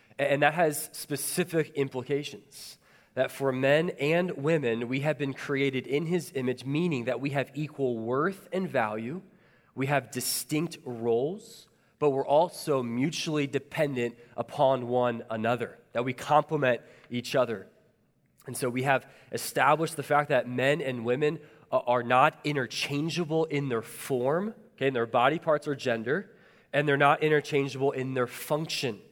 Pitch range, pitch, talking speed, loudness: 125-155 Hz, 140 Hz, 150 wpm, -28 LUFS